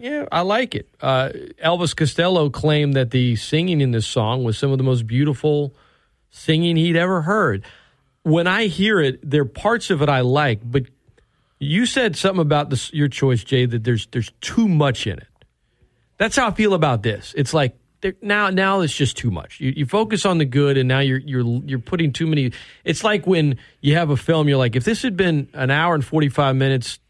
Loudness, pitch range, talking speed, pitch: -19 LUFS, 130-175 Hz, 215 wpm, 145 Hz